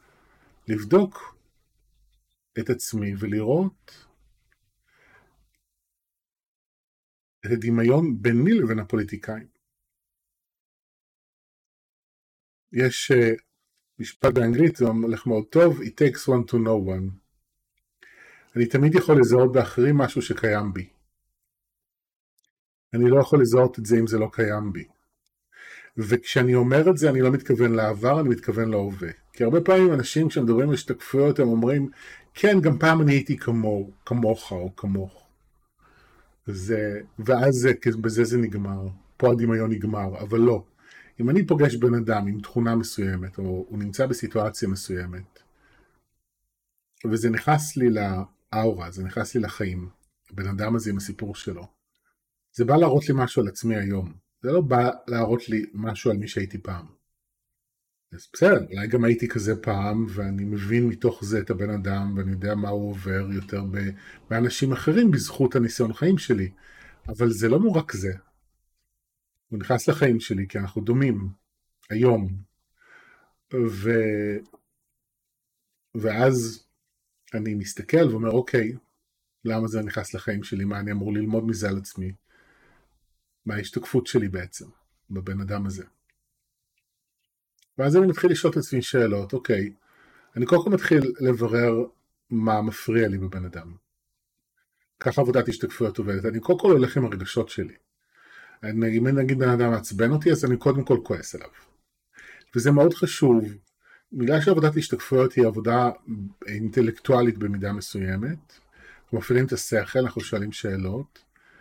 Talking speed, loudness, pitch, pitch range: 135 wpm, -23 LUFS, 115 Hz, 105-130 Hz